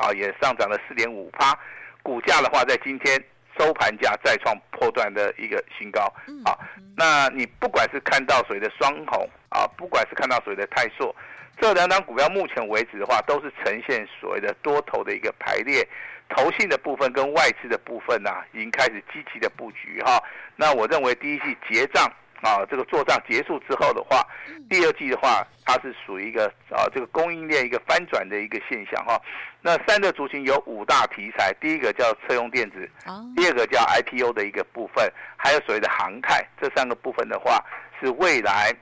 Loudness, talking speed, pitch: -23 LUFS, 305 characters per minute, 205 Hz